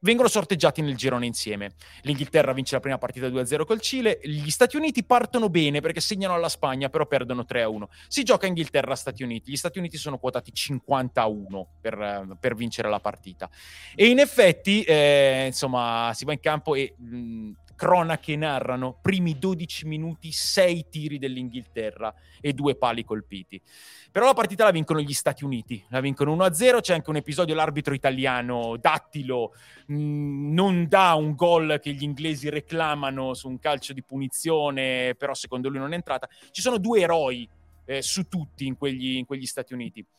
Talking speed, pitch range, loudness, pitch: 170 wpm, 125-160 Hz, -24 LUFS, 140 Hz